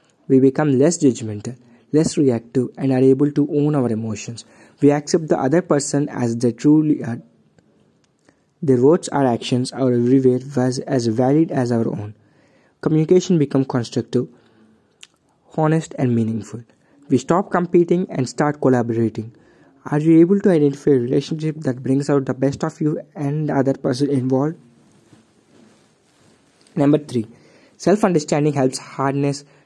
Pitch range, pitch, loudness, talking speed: 125-150 Hz, 135 Hz, -18 LUFS, 145 wpm